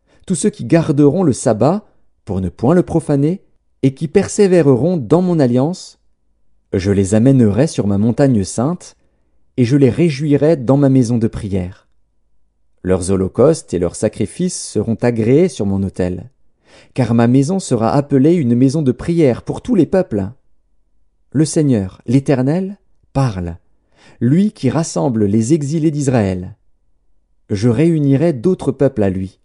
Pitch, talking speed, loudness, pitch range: 130 Hz, 145 wpm, -15 LUFS, 100-160 Hz